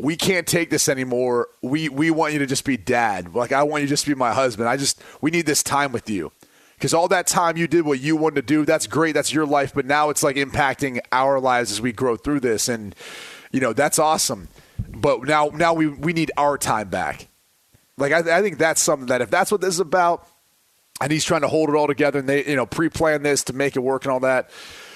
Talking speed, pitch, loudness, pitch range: 255 wpm, 145 Hz, -20 LUFS, 135-160 Hz